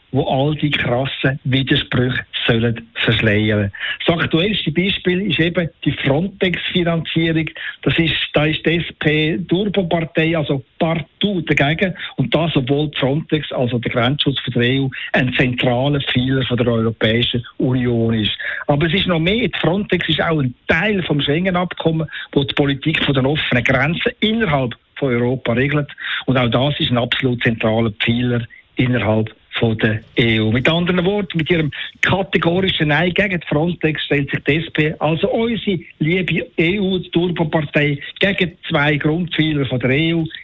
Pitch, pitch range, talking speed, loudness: 150 Hz, 130-170 Hz, 145 wpm, -17 LUFS